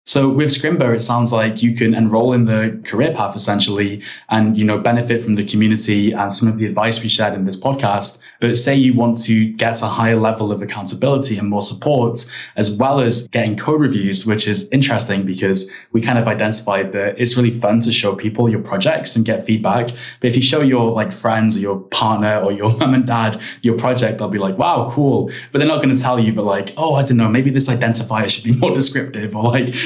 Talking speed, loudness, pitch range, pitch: 230 wpm, -16 LUFS, 105-120 Hz, 115 Hz